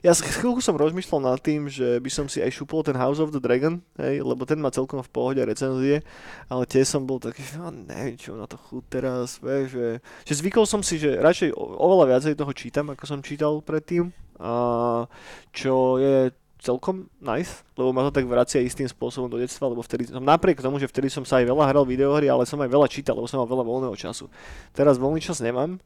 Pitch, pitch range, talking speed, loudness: 135 Hz, 125-150 Hz, 220 wpm, -24 LUFS